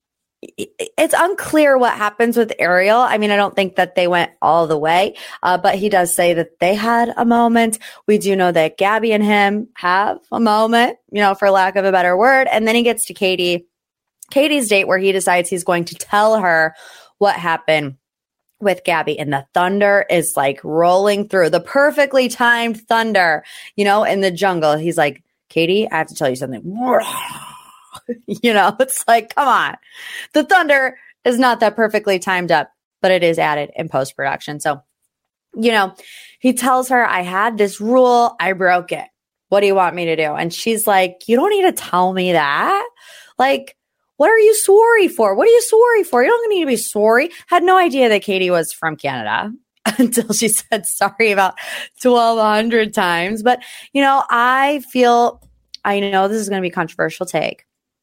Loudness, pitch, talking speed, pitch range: -15 LUFS, 210 Hz, 195 wpm, 180-245 Hz